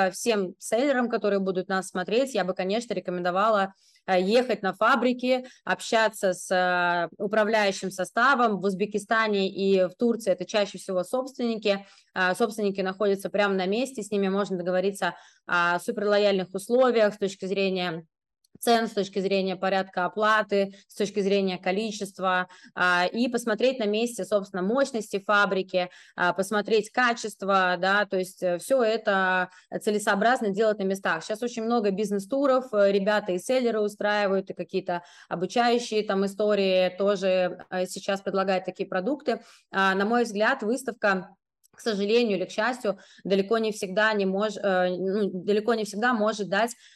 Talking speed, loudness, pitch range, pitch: 135 wpm, -26 LUFS, 185-220 Hz, 200 Hz